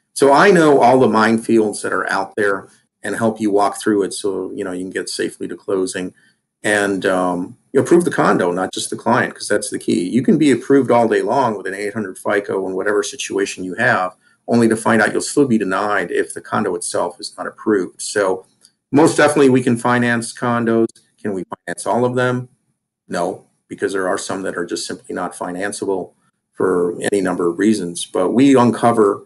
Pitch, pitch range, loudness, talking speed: 115 Hz, 100-125 Hz, -17 LUFS, 210 wpm